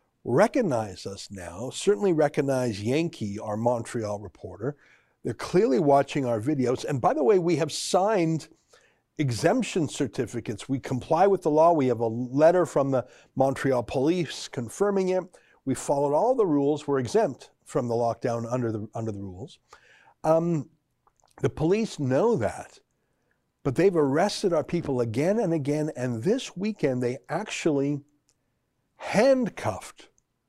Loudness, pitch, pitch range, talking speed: -26 LUFS, 140 Hz, 120-165 Hz, 140 wpm